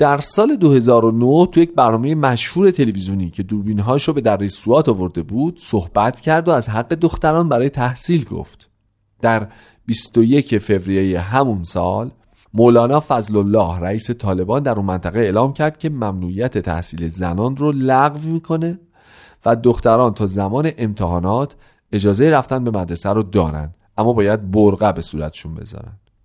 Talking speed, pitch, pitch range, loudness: 145 wpm, 115 Hz, 100-135 Hz, -17 LUFS